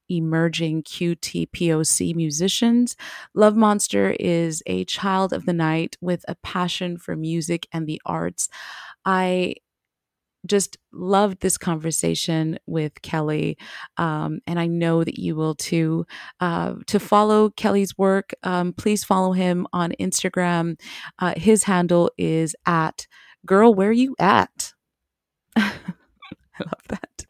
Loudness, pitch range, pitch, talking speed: -21 LUFS, 160-195 Hz, 175 Hz, 125 wpm